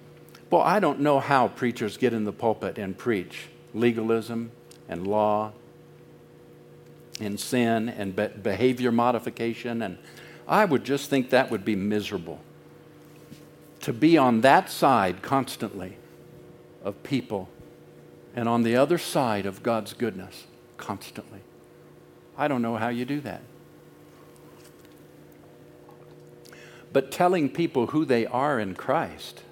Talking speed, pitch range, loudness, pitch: 125 wpm, 115-140 Hz, -25 LUFS, 120 Hz